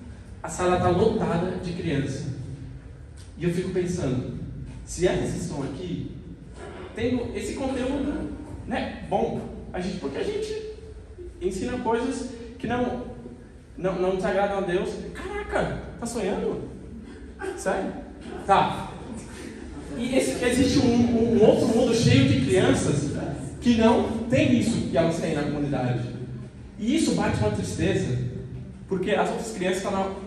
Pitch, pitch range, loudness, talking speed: 190 Hz, 145-240 Hz, -25 LUFS, 135 wpm